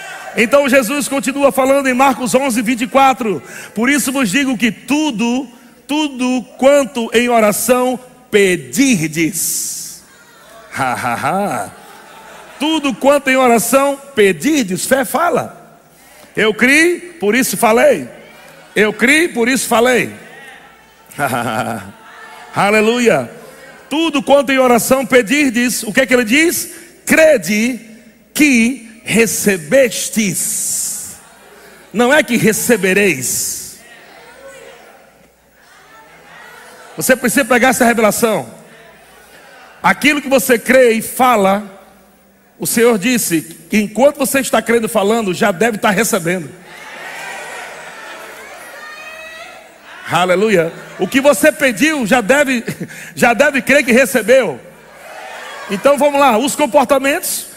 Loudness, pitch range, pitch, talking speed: -13 LUFS, 215-275 Hz, 250 Hz, 105 wpm